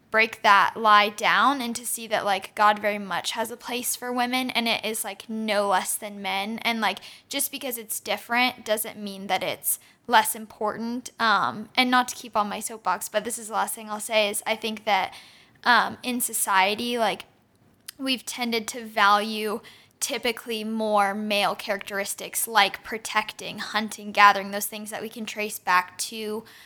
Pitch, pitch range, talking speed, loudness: 215 Hz, 205-230 Hz, 180 wpm, -24 LUFS